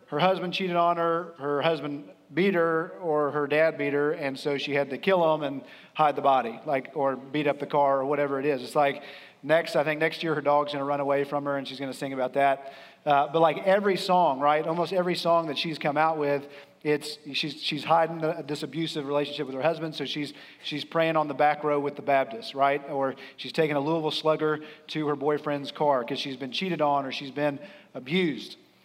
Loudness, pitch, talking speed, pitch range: -27 LUFS, 150 Hz, 230 wpm, 140-160 Hz